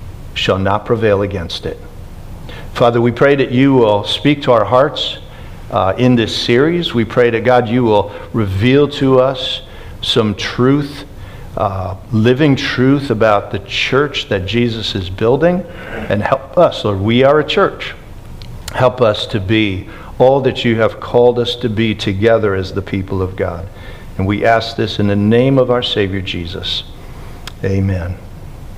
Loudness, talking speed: -14 LUFS, 165 wpm